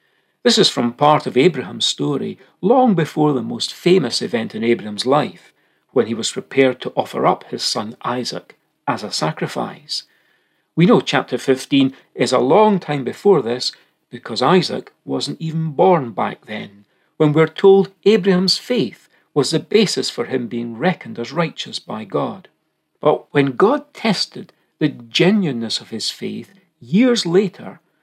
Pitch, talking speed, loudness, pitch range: 155 Hz, 155 wpm, -18 LUFS, 125-195 Hz